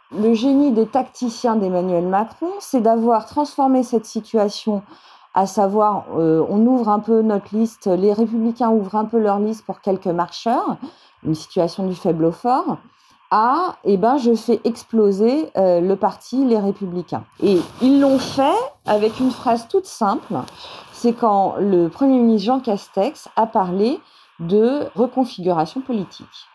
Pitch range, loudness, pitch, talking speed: 195-255 Hz, -19 LUFS, 220 Hz, 155 wpm